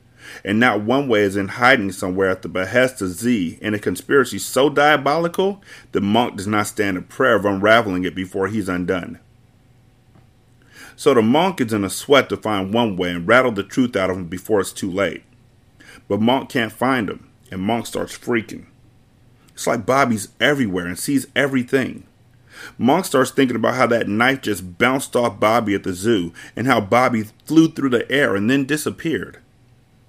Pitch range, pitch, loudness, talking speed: 95-125 Hz, 115 Hz, -19 LUFS, 185 wpm